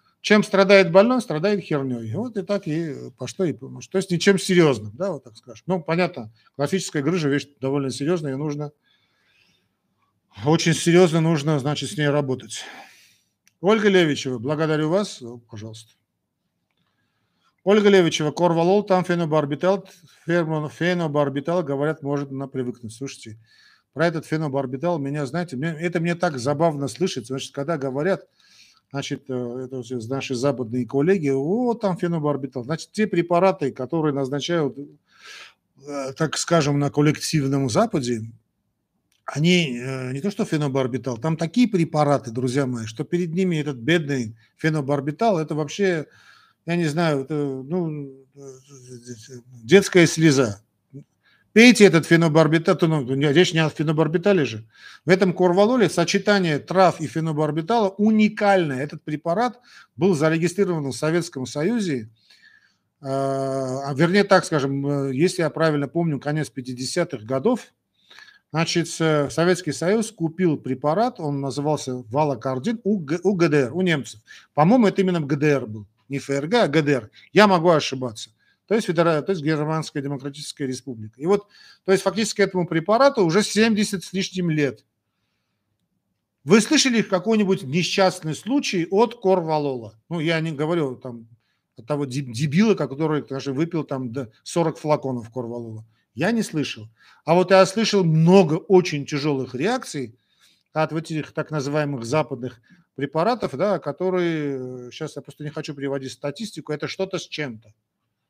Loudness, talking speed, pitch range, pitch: -21 LUFS, 135 wpm, 135-180 Hz, 155 Hz